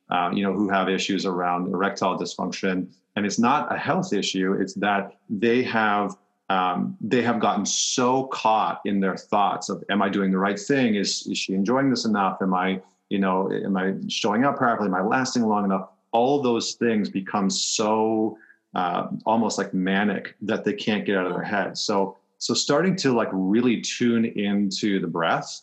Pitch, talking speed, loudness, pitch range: 100 Hz, 190 wpm, -24 LUFS, 95-110 Hz